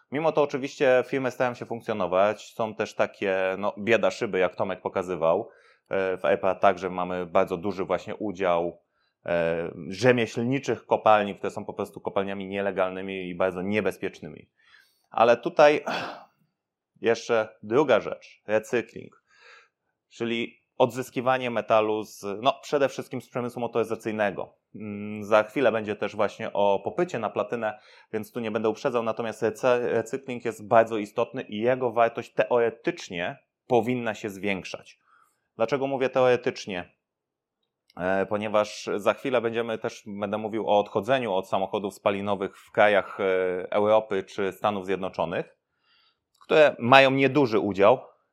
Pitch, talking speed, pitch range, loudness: 110 Hz, 125 wpm, 100-120 Hz, -26 LUFS